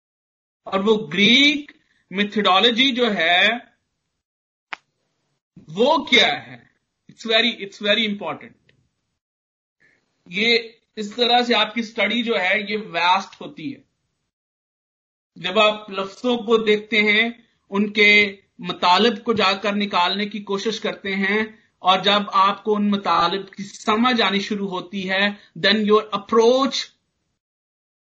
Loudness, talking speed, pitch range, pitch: -18 LUFS, 115 wpm, 195-225 Hz, 210 Hz